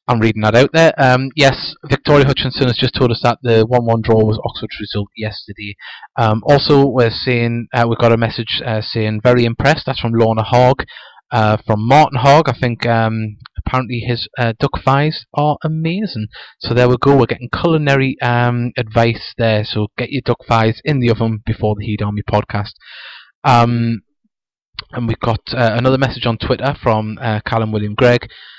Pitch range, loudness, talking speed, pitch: 110-135 Hz, -15 LUFS, 190 wpm, 120 Hz